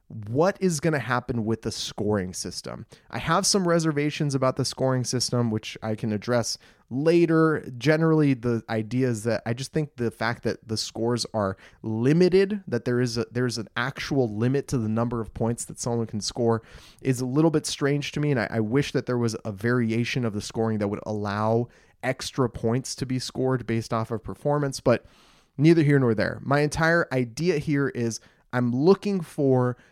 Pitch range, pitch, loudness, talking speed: 115-145 Hz, 125 Hz, -25 LUFS, 195 wpm